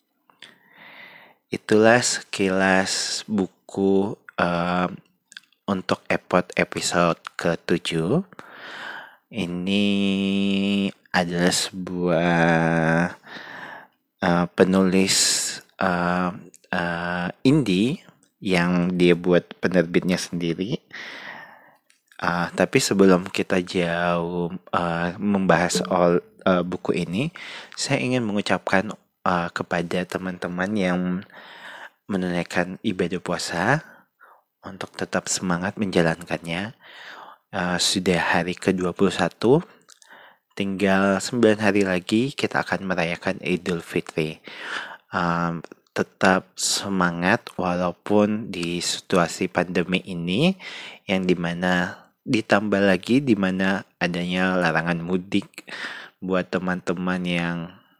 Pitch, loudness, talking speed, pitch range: 90 Hz, -23 LUFS, 80 wpm, 85-95 Hz